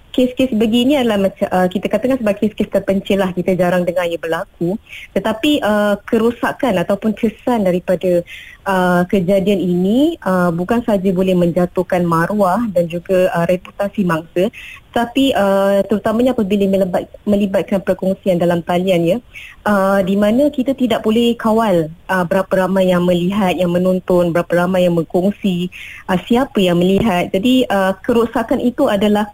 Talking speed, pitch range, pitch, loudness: 150 wpm, 180-220 Hz, 195 Hz, -16 LUFS